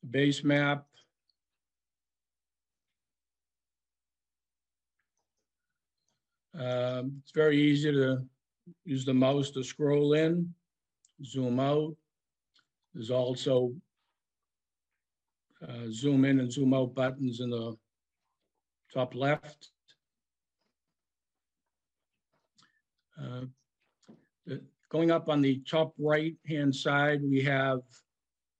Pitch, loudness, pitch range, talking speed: 130 Hz, -29 LUFS, 115-145 Hz, 80 wpm